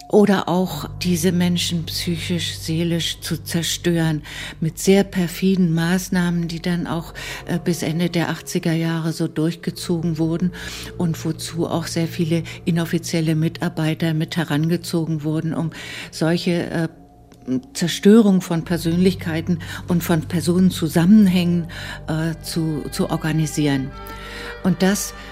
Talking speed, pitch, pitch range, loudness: 115 wpm, 165 Hz, 160-175 Hz, -20 LUFS